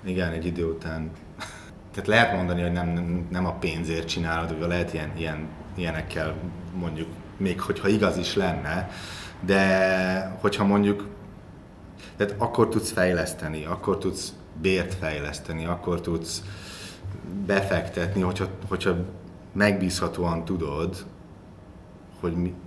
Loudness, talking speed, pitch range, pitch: -26 LUFS, 115 wpm, 85-95 Hz, 90 Hz